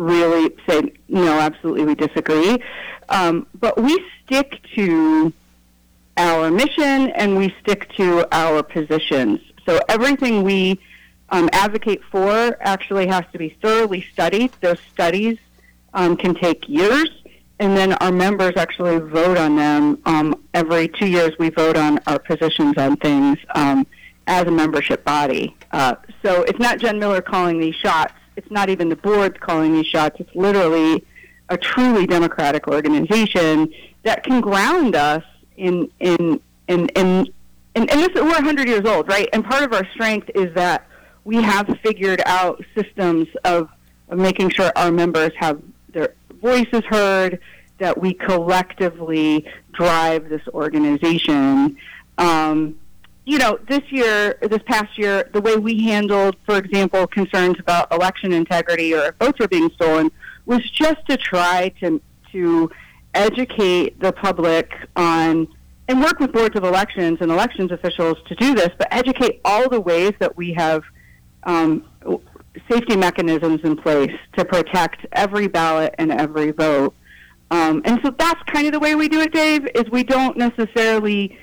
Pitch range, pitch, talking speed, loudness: 165-220 Hz, 185 Hz, 155 wpm, -18 LUFS